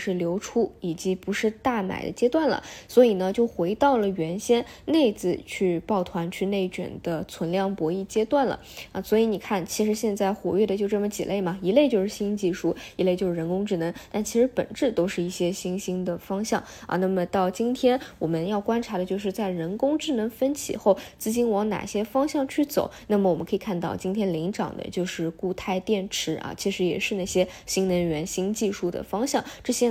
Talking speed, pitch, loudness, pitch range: 305 characters per minute, 195 Hz, -26 LUFS, 180-220 Hz